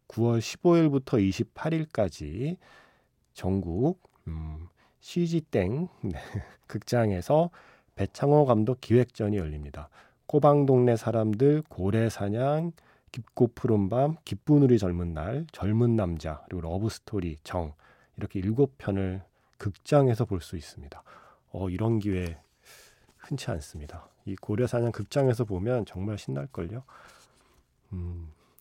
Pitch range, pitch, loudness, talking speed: 90-130 Hz, 110 Hz, -27 LUFS, 230 characters per minute